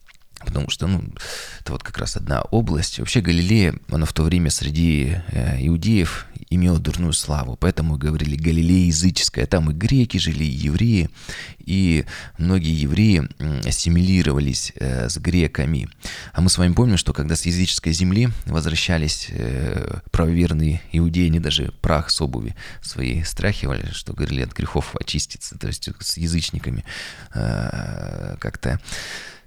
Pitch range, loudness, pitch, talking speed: 75-90 Hz, -21 LUFS, 85 Hz, 135 wpm